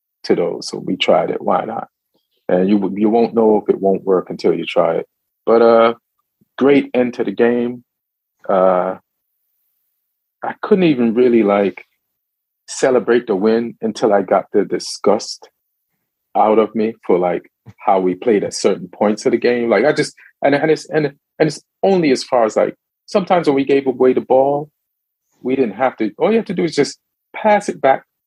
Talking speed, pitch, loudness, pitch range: 195 wpm, 120 Hz, -16 LUFS, 110-145 Hz